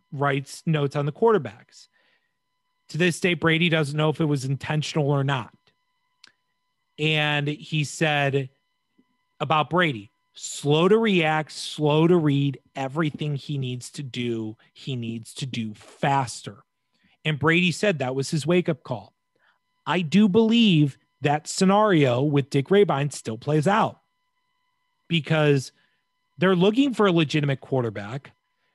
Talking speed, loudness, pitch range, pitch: 135 wpm, -23 LUFS, 140-195 Hz, 155 Hz